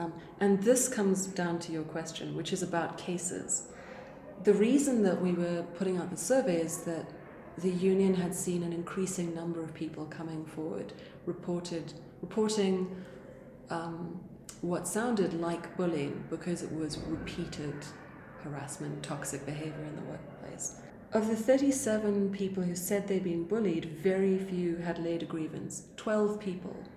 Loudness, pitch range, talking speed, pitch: -33 LUFS, 165-190 Hz, 150 wpm, 175 Hz